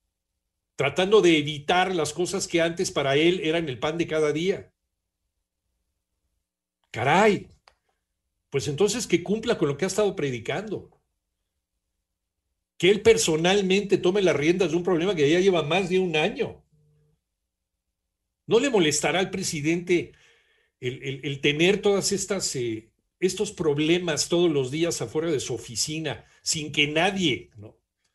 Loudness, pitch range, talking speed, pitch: -24 LUFS, 140-185 Hz, 140 wpm, 160 Hz